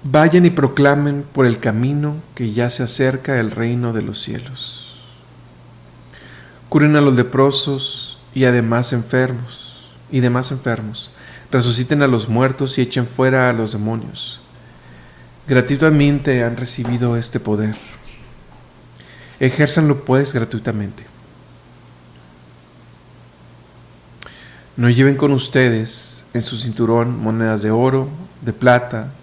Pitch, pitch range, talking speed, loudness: 120 Hz, 110-135 Hz, 115 wpm, -17 LUFS